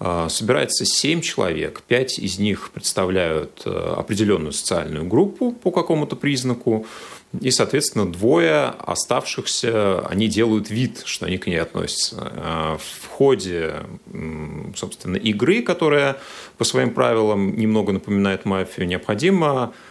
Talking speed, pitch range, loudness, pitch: 110 wpm, 95-140 Hz, -20 LUFS, 110 Hz